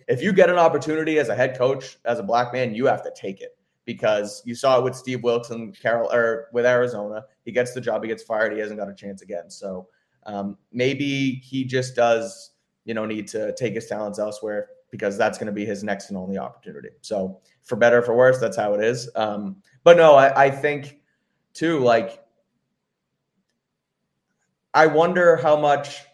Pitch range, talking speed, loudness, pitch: 110-145 Hz, 205 wpm, -21 LUFS, 125 Hz